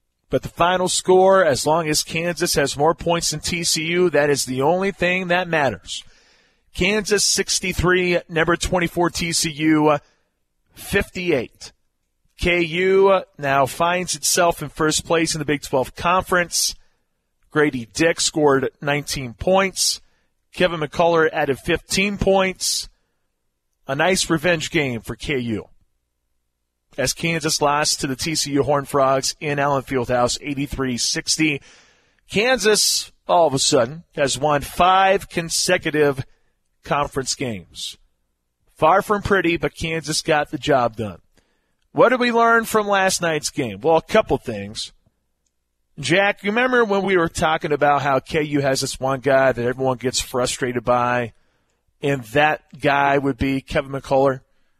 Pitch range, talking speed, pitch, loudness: 135-175 Hz, 135 wpm, 150 Hz, -19 LUFS